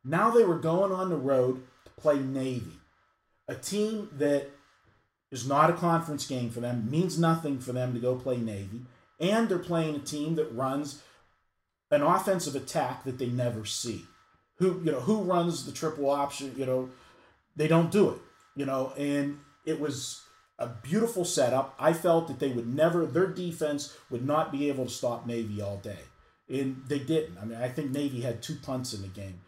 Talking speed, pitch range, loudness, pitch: 195 wpm, 125-160 Hz, -29 LUFS, 140 Hz